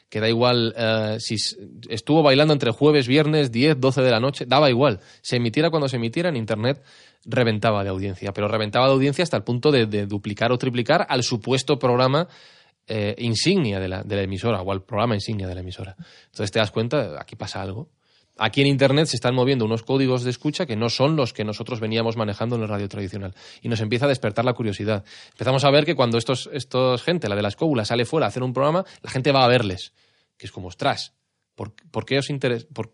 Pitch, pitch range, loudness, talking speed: 120 Hz, 110-140 Hz, -22 LUFS, 230 wpm